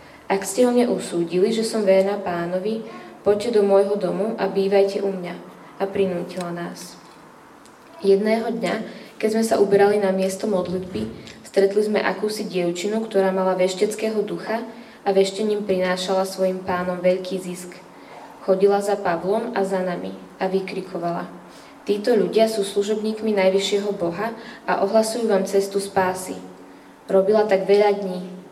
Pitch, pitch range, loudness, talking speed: 195 Hz, 185-210 Hz, -21 LUFS, 140 wpm